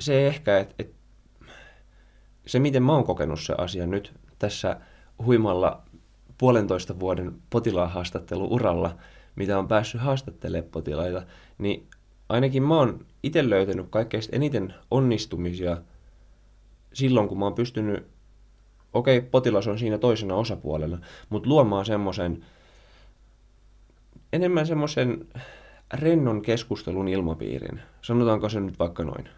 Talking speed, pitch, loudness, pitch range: 115 wpm, 105 Hz, -25 LUFS, 90-120 Hz